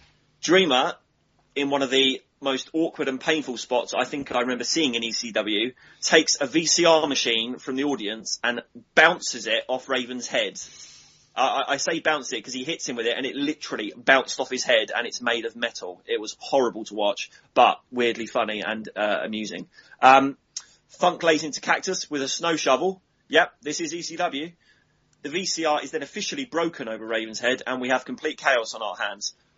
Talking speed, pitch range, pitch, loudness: 190 wpm, 125-160 Hz, 135 Hz, -24 LUFS